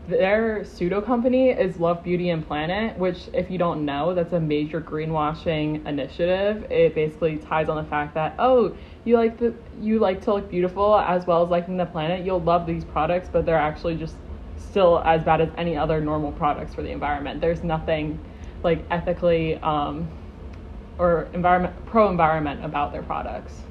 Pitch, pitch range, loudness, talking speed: 170 Hz, 155-180 Hz, -23 LUFS, 175 wpm